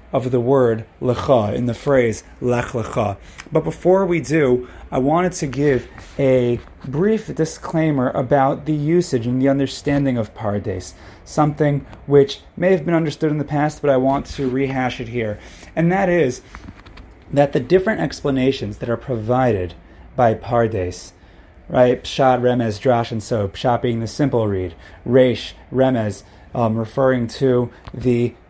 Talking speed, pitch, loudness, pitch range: 155 wpm, 125 Hz, -19 LUFS, 110-140 Hz